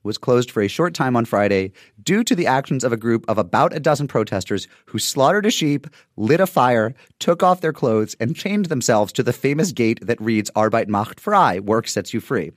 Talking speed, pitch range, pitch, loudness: 225 wpm, 110-155 Hz, 120 Hz, -19 LUFS